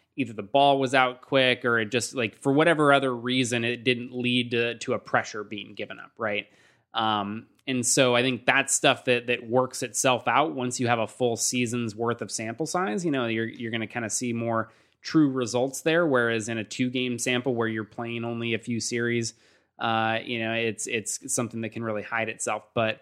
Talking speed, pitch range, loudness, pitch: 220 wpm, 115-130 Hz, -26 LUFS, 120 Hz